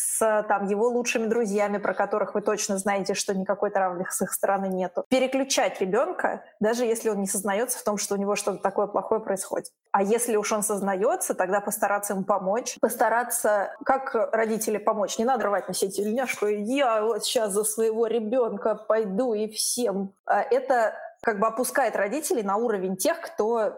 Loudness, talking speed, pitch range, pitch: -25 LUFS, 175 wpm, 200-235 Hz, 215 Hz